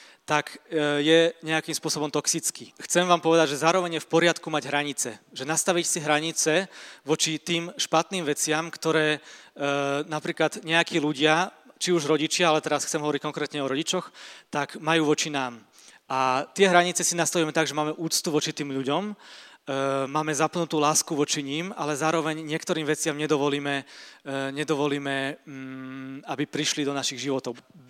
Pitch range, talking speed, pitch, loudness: 145-165 Hz, 155 wpm, 155 Hz, -25 LUFS